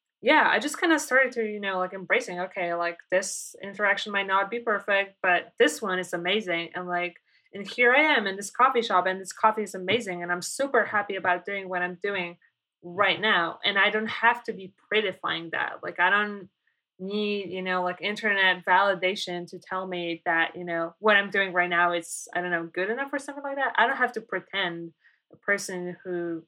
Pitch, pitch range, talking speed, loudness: 190 Hz, 180-210 Hz, 220 wpm, -25 LUFS